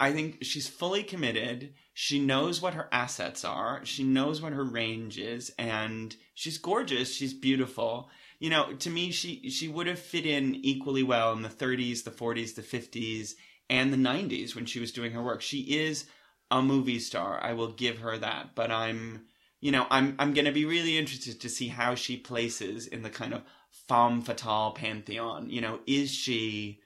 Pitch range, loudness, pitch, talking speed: 115-140 Hz, -30 LUFS, 130 Hz, 195 wpm